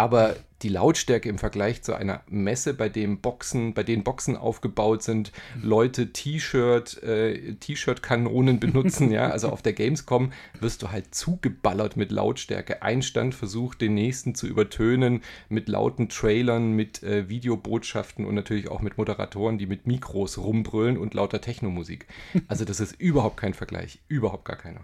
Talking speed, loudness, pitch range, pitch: 160 wpm, -26 LUFS, 105-125 Hz, 110 Hz